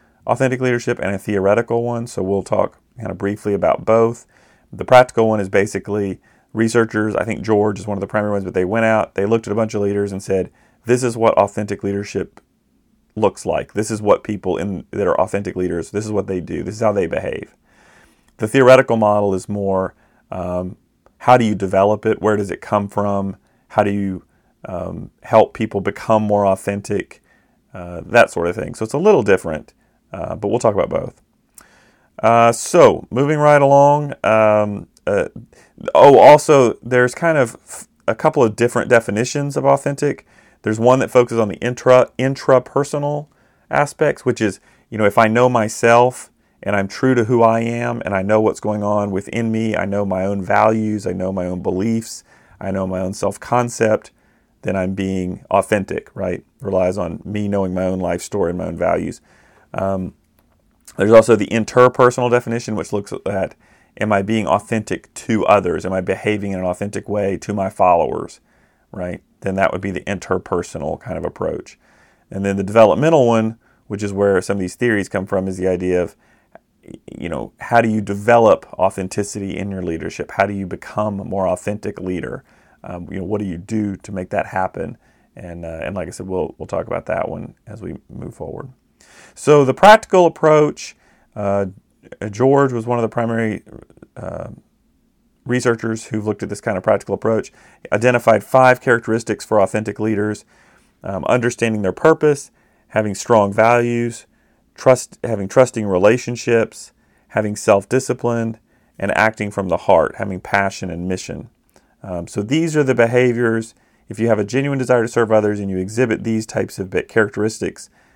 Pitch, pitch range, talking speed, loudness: 105 Hz, 100-120 Hz, 185 wpm, -17 LUFS